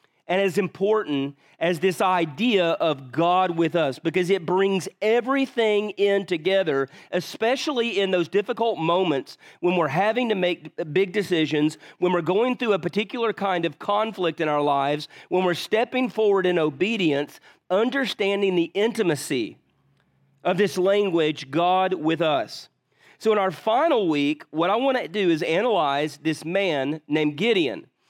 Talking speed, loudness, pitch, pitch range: 150 wpm, -23 LUFS, 185 Hz, 165-210 Hz